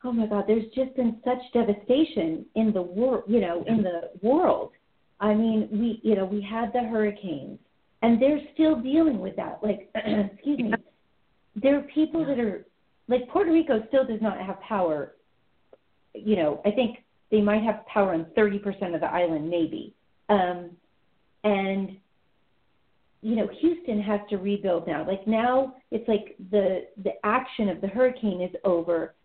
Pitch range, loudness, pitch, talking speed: 200-250 Hz, -26 LUFS, 215 Hz, 170 wpm